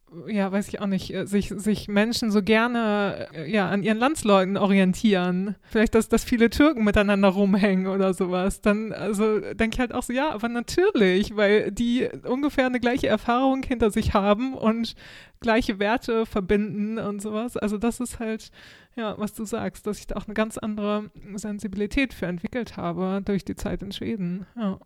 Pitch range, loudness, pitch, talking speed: 200-230 Hz, -24 LUFS, 210 Hz, 180 wpm